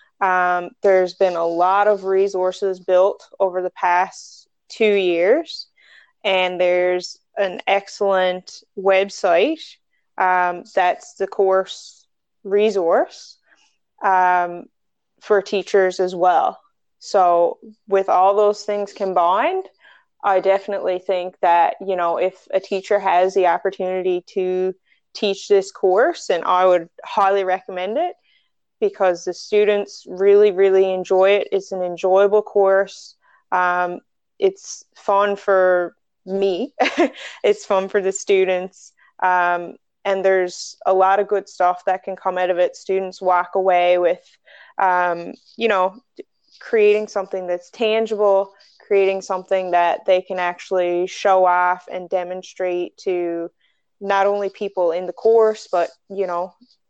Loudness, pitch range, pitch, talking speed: -19 LUFS, 180-200 Hz, 190 Hz, 130 wpm